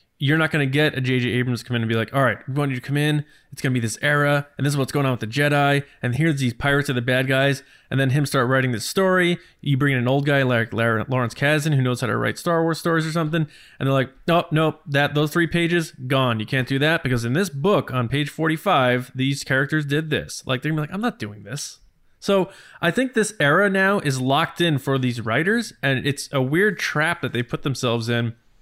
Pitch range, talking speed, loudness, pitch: 130-160 Hz, 265 wpm, -21 LUFS, 140 Hz